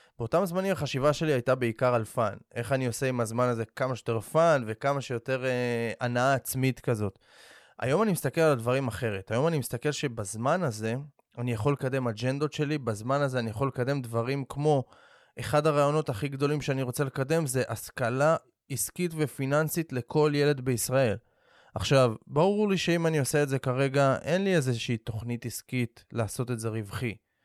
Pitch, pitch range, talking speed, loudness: 130 Hz, 120-150 Hz, 170 wpm, -28 LUFS